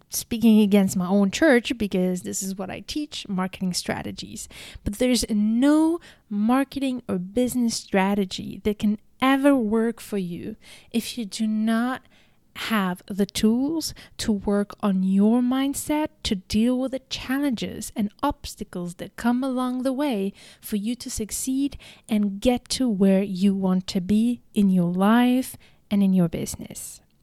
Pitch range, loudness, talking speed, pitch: 200-255 Hz, -24 LUFS, 150 wpm, 220 Hz